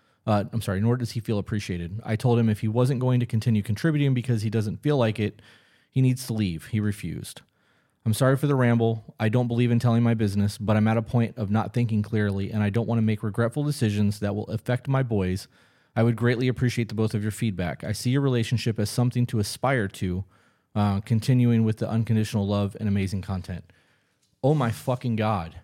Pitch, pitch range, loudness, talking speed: 110 Hz, 105-120 Hz, -25 LUFS, 220 wpm